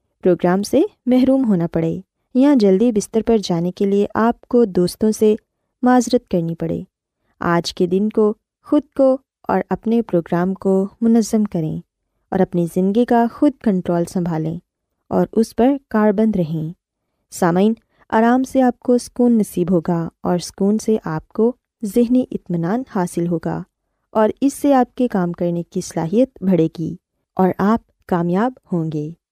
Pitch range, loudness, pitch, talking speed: 175-240 Hz, -18 LUFS, 205 Hz, 155 wpm